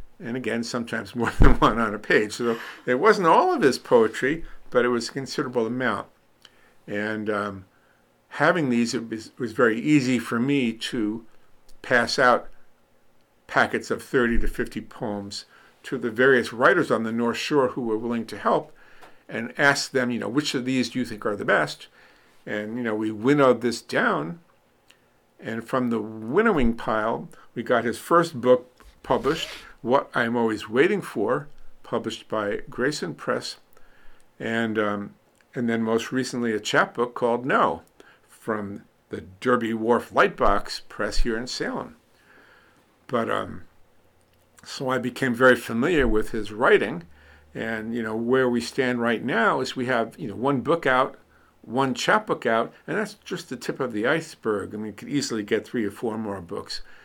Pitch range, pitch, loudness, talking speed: 110-125 Hz, 115 Hz, -24 LUFS, 170 wpm